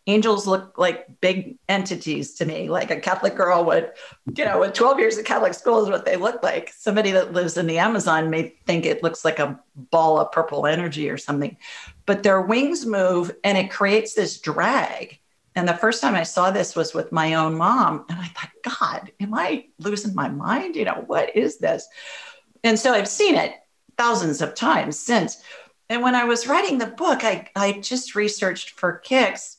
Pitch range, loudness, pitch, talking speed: 170-235 Hz, -21 LUFS, 200 Hz, 205 wpm